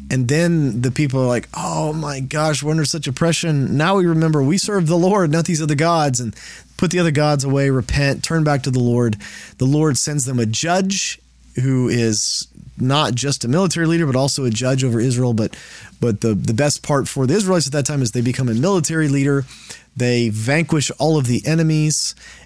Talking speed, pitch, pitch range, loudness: 210 wpm, 140 Hz, 125-160 Hz, -18 LUFS